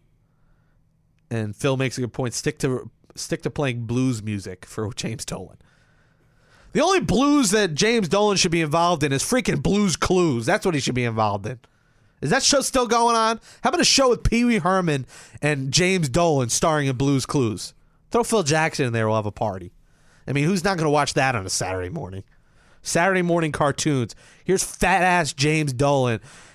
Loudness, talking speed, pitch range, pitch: -21 LUFS, 200 wpm, 125-185 Hz, 150 Hz